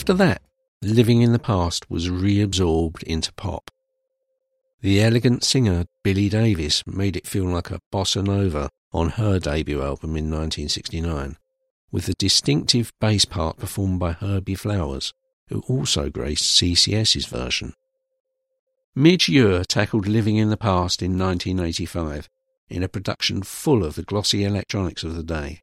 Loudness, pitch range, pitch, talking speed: -21 LUFS, 90-120 Hz, 100 Hz, 145 wpm